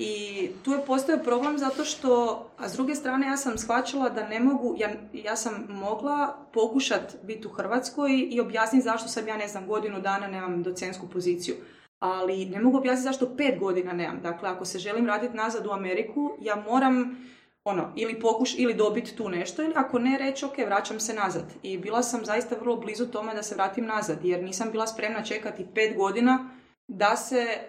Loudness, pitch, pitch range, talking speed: -28 LUFS, 225 Hz, 200-255 Hz, 195 wpm